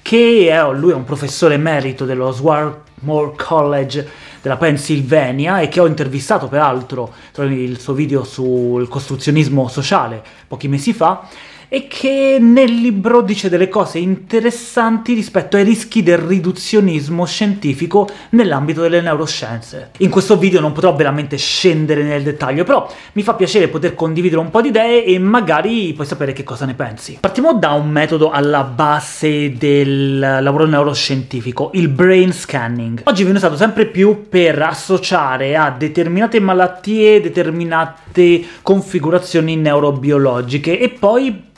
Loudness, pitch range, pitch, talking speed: -14 LUFS, 145-195 Hz, 160 Hz, 140 wpm